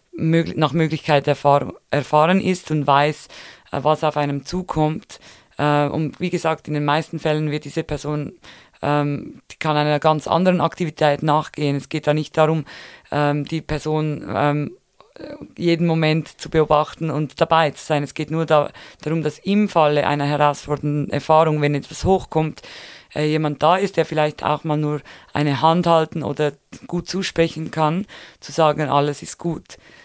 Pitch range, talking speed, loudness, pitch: 145-160 Hz, 150 wpm, -20 LUFS, 155 Hz